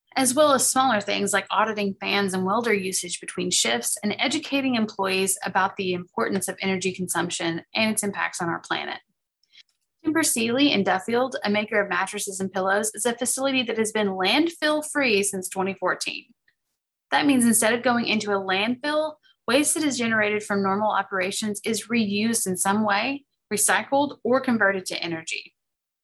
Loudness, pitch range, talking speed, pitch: -23 LUFS, 190-255 Hz, 170 wpm, 210 Hz